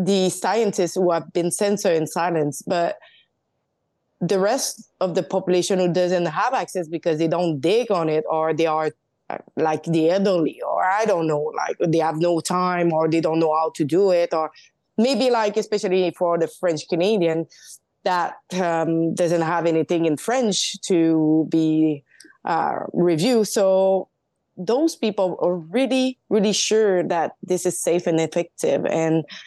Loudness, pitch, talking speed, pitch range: -21 LUFS, 175 Hz, 165 wpm, 160-195 Hz